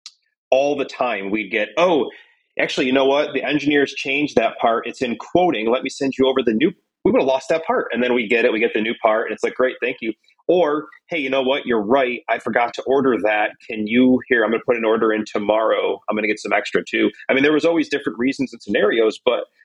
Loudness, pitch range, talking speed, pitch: -19 LUFS, 125-165 Hz, 265 wpm, 135 Hz